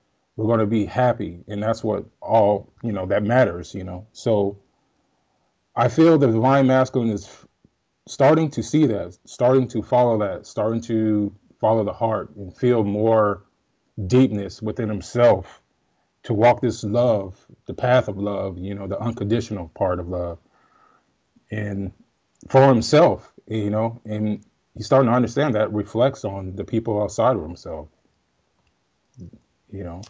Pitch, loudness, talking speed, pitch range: 110 Hz, -21 LUFS, 155 wpm, 100-120 Hz